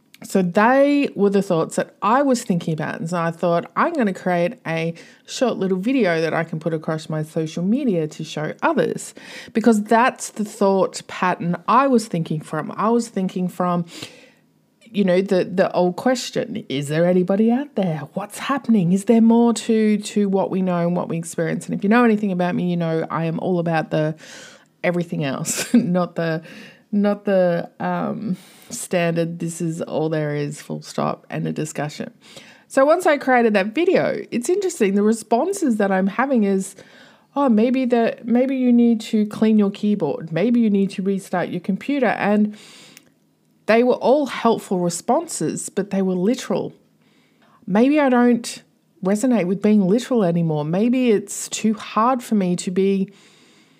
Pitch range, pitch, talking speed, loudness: 175-235 Hz, 200 Hz, 180 wpm, -20 LUFS